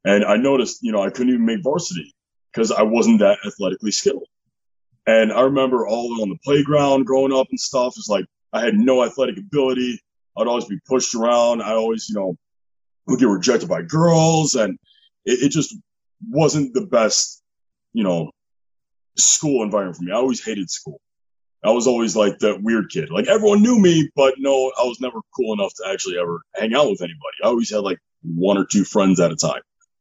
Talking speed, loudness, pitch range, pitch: 205 wpm, -19 LUFS, 110-155 Hz, 130 Hz